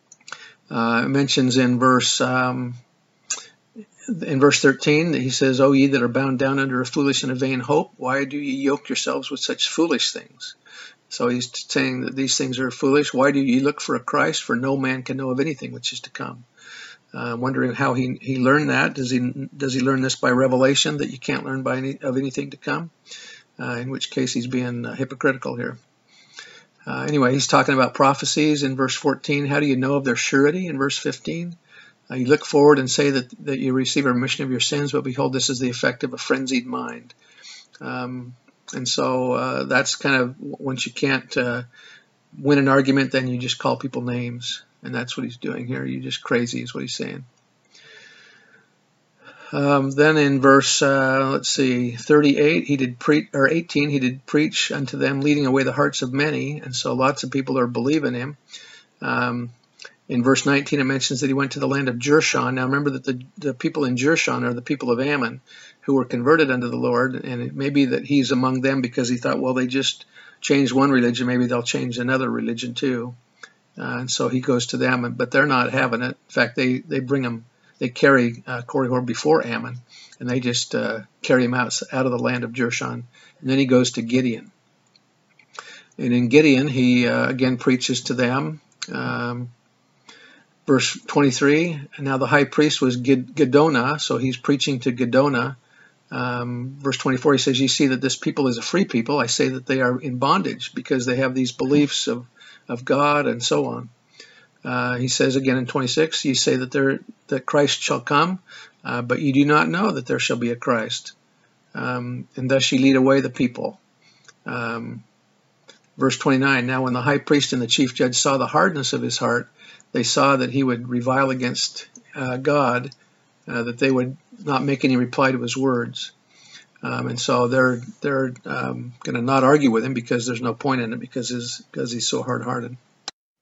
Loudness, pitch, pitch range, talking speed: -21 LUFS, 130 Hz, 125-140 Hz, 205 wpm